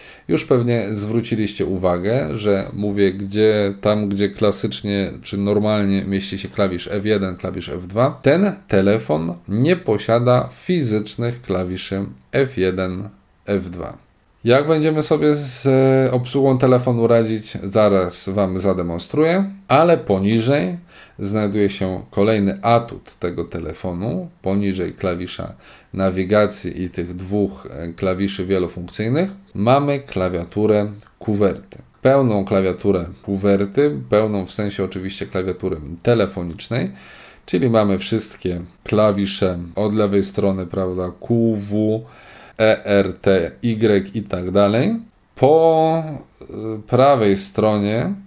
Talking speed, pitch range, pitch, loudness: 105 wpm, 95-115 Hz, 105 Hz, -19 LUFS